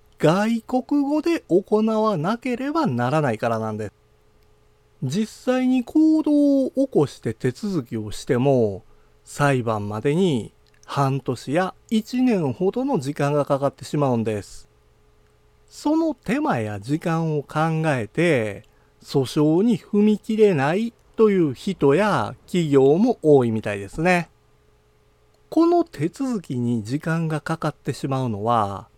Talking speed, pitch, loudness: 240 characters per minute, 155 Hz, -22 LUFS